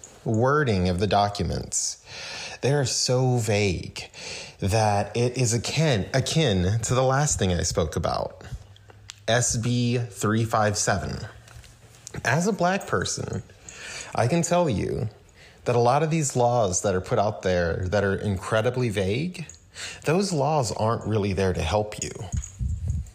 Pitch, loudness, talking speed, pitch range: 110 Hz, -24 LUFS, 135 wpm, 100-125 Hz